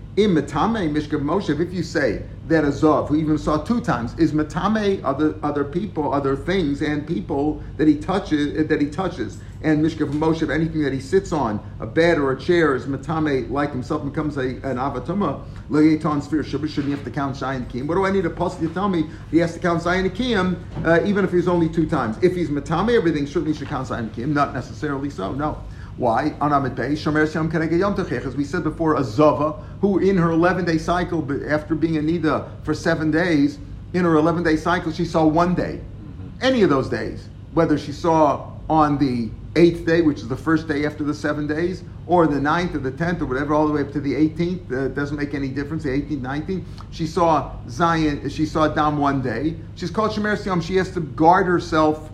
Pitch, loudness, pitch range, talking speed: 155 Hz, -21 LUFS, 140-170 Hz, 205 wpm